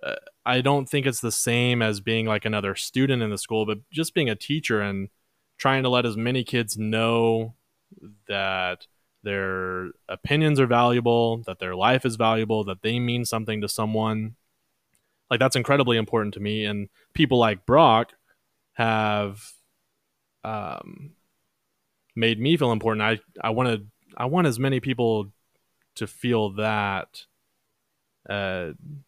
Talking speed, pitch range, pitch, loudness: 145 wpm, 105-130 Hz, 115 Hz, -24 LUFS